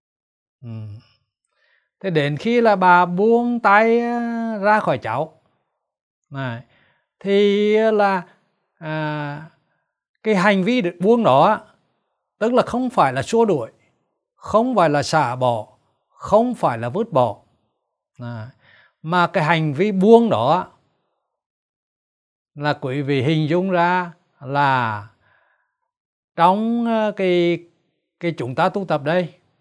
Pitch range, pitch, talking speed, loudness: 140-210 Hz, 175 Hz, 120 wpm, -18 LUFS